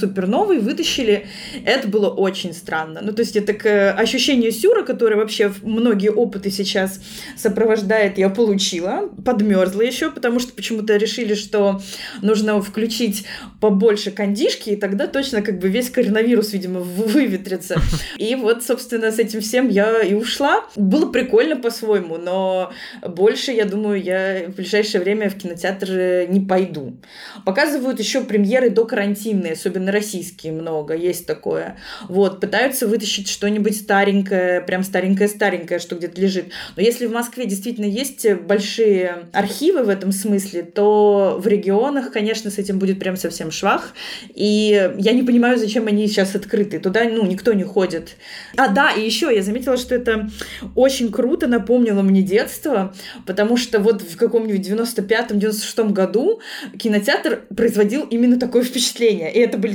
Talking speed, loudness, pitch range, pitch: 150 wpm, -18 LUFS, 195-235 Hz, 210 Hz